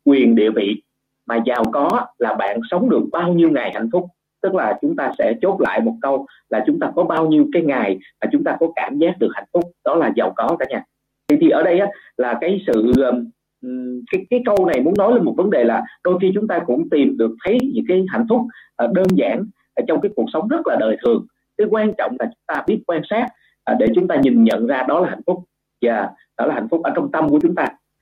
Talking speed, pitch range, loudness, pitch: 255 wpm, 160-240 Hz, -18 LUFS, 185 Hz